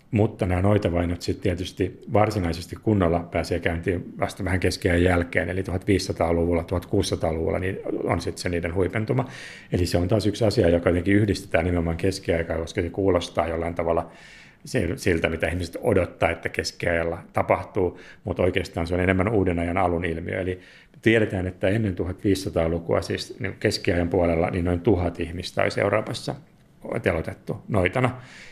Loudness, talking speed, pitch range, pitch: -24 LUFS, 145 wpm, 85-100 Hz, 90 Hz